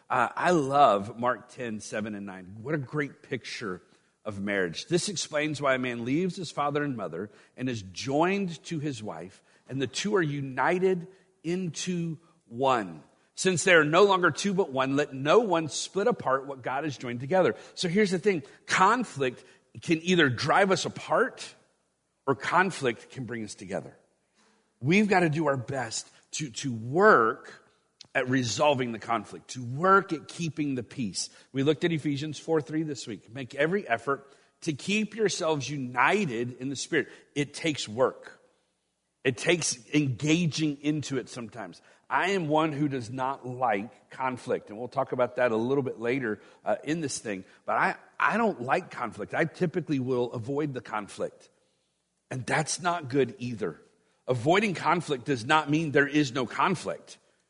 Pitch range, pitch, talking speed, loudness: 125-170 Hz, 145 Hz, 170 wpm, -28 LUFS